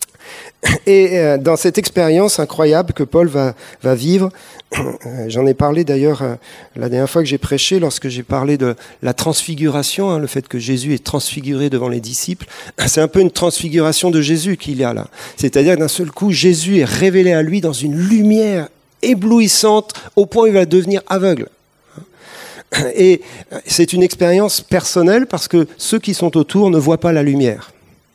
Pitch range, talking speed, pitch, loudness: 140-190 Hz, 185 wpm, 165 Hz, -14 LUFS